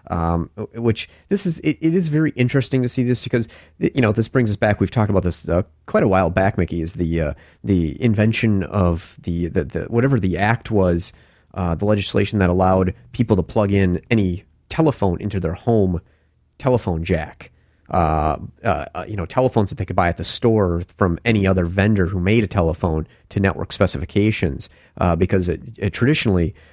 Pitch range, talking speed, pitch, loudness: 85-115 Hz, 195 wpm, 95 Hz, -20 LUFS